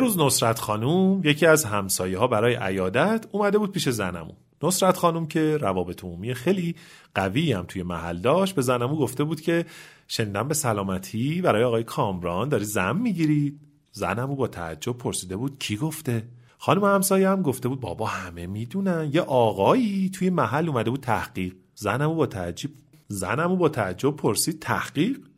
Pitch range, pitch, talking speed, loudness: 105-165 Hz, 135 Hz, 160 wpm, -24 LUFS